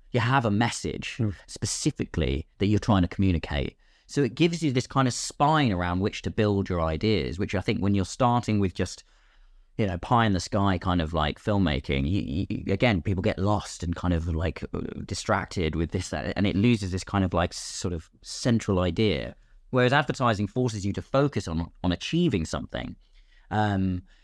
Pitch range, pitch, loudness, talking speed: 90-115 Hz, 100 Hz, -26 LUFS, 195 wpm